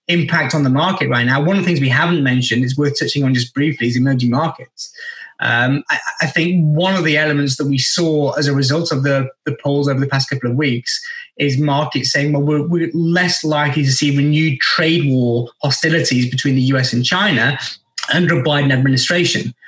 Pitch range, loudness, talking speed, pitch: 135-165 Hz, -15 LUFS, 210 wpm, 145 Hz